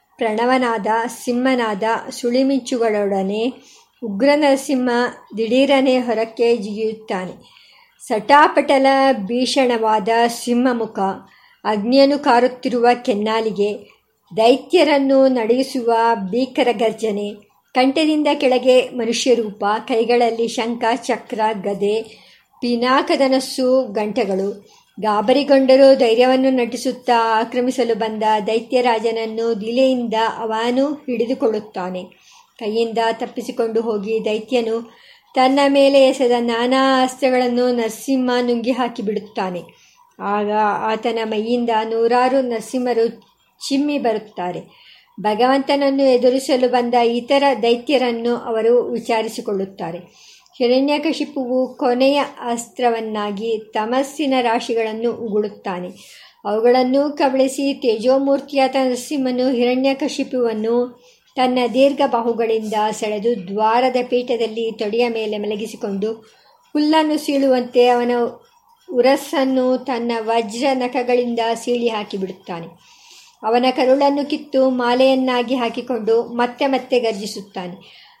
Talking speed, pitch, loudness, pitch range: 80 wpm, 240 Hz, -18 LUFS, 225-260 Hz